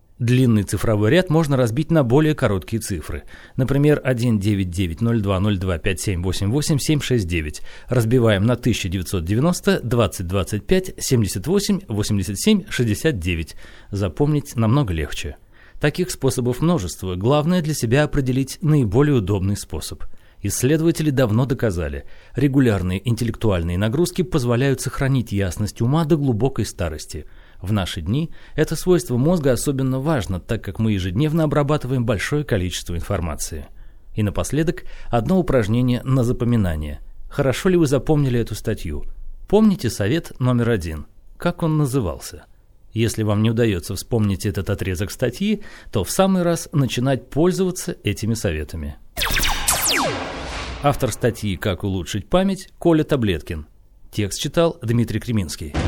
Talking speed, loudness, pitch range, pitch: 120 wpm, -20 LUFS, 100-145 Hz, 115 Hz